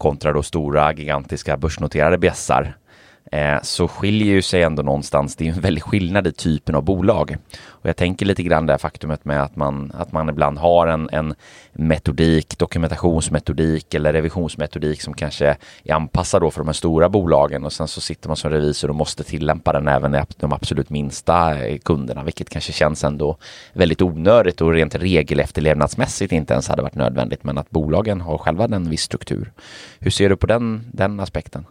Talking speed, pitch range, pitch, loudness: 185 wpm, 75-85 Hz, 80 Hz, -19 LUFS